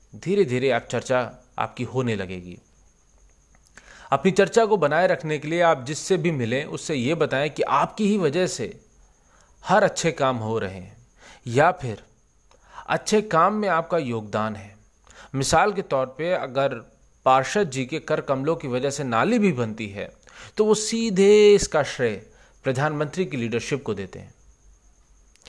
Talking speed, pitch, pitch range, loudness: 160 wpm, 135 Hz, 110-175 Hz, -23 LUFS